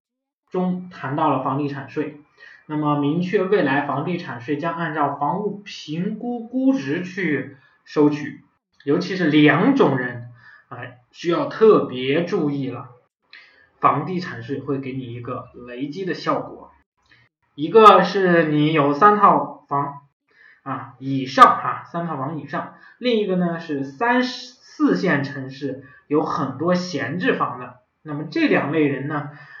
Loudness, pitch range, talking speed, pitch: -20 LUFS, 140-180 Hz, 205 characters per minute, 150 Hz